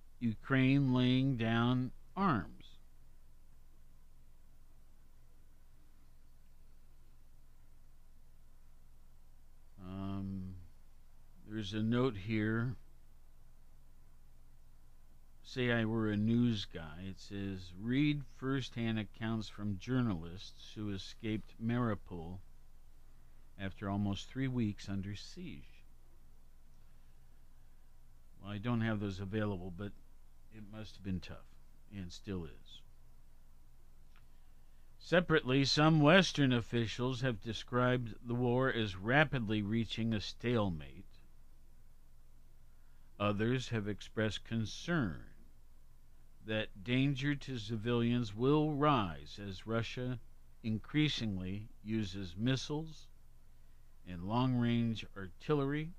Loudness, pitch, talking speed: -36 LUFS, 95 Hz, 85 wpm